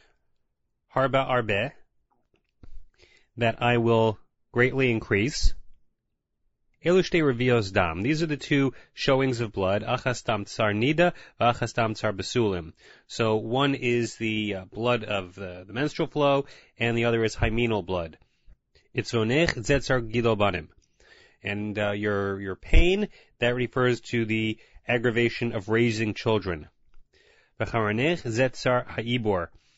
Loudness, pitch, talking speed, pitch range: -26 LUFS, 115 Hz, 85 wpm, 105-125 Hz